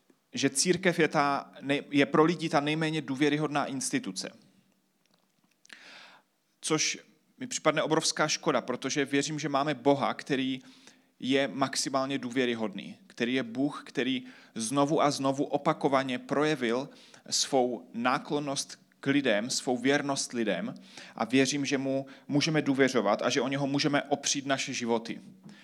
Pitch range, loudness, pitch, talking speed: 135-155 Hz, -29 LUFS, 140 Hz, 130 wpm